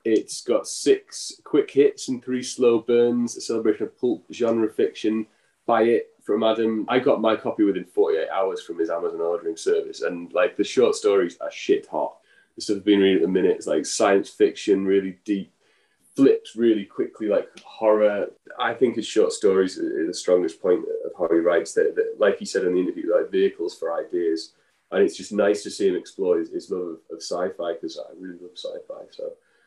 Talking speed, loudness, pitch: 205 wpm, -23 LUFS, 400 Hz